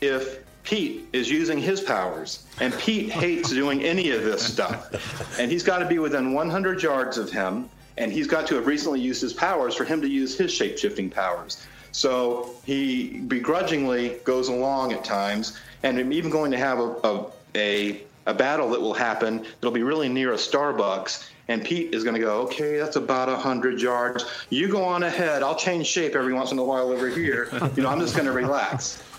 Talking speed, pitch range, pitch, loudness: 205 wpm, 125-170 Hz, 130 Hz, -25 LUFS